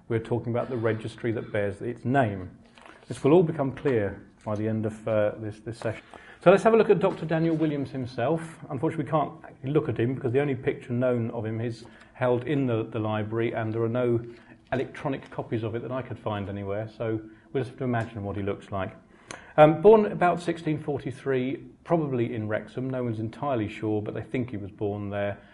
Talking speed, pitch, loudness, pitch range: 220 wpm, 120 Hz, -27 LUFS, 110-140 Hz